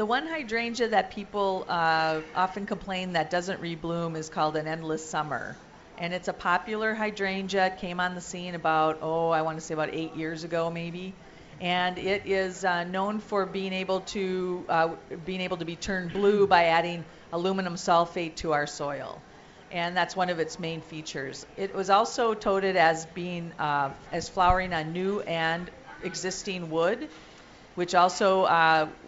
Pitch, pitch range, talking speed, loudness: 180 Hz, 165-190 Hz, 175 wpm, -28 LUFS